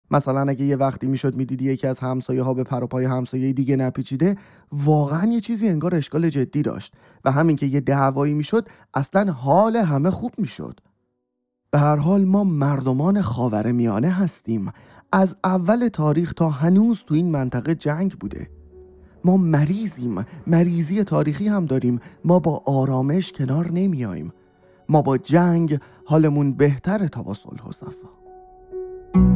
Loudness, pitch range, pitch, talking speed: -21 LUFS, 130-185 Hz, 150 Hz, 145 wpm